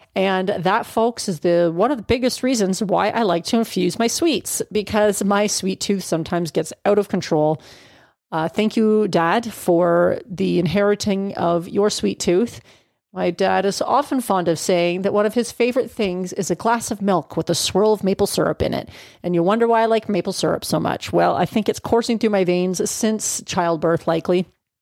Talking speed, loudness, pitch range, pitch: 205 wpm, -20 LUFS, 175-220 Hz, 195 Hz